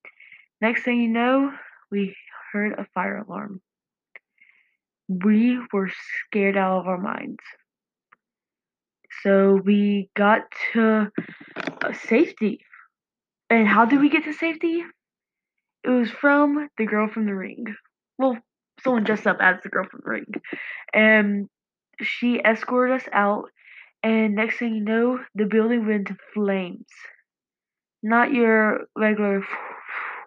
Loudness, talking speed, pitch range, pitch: -22 LUFS, 125 wpm, 205-250 Hz, 220 Hz